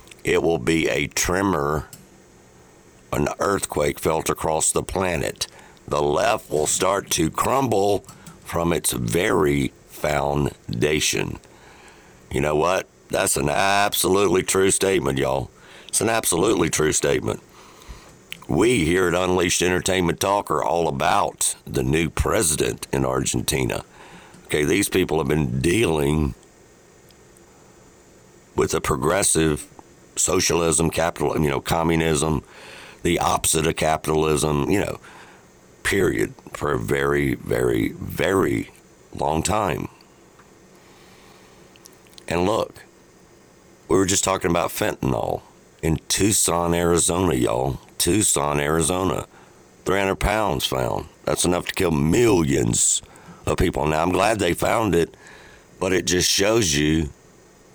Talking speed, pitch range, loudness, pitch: 115 wpm, 70-90 Hz, -21 LUFS, 80 Hz